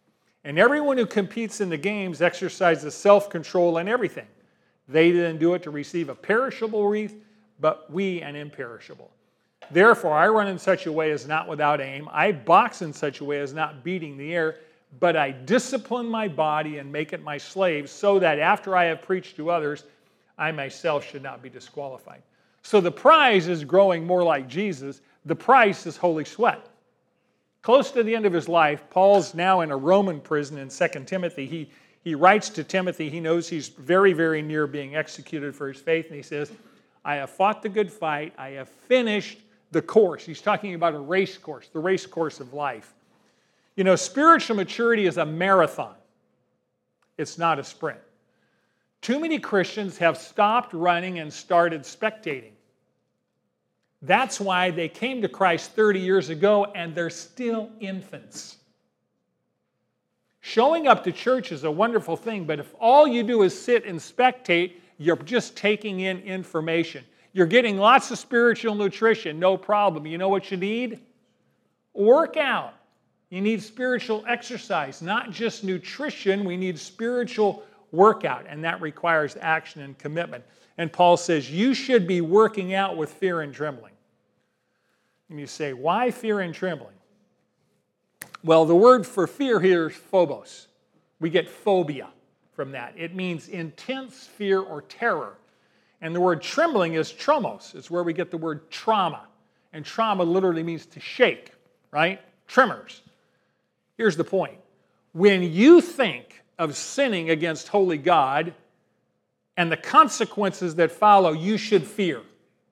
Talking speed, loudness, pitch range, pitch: 160 wpm, -23 LUFS, 160-210 Hz, 180 Hz